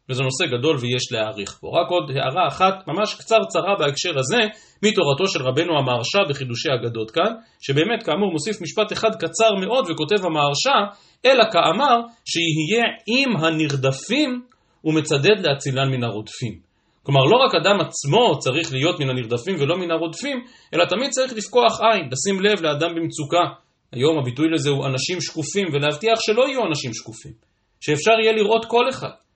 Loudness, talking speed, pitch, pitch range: -20 LUFS, 155 wpm, 165 Hz, 140-215 Hz